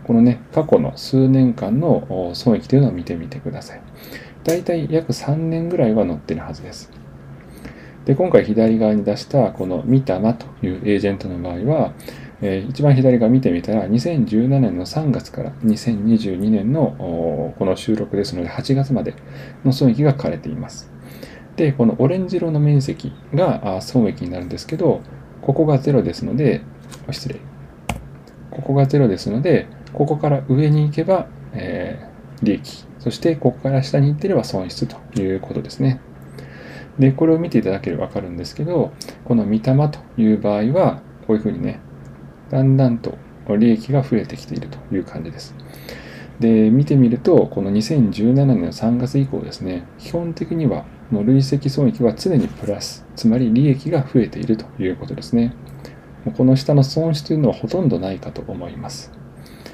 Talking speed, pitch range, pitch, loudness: 320 characters per minute, 110-140 Hz, 125 Hz, -18 LUFS